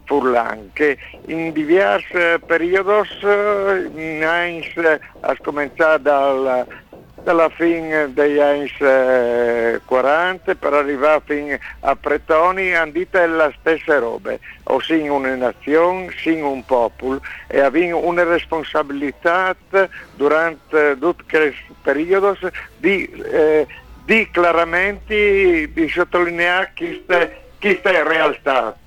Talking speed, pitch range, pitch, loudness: 100 wpm, 145-190 Hz, 165 Hz, -17 LUFS